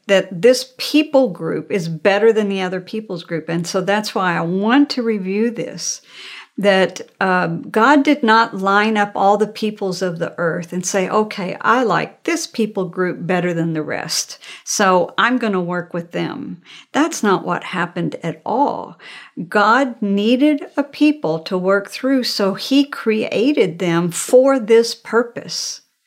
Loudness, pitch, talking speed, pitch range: -17 LUFS, 200 Hz, 165 wpm, 180-235 Hz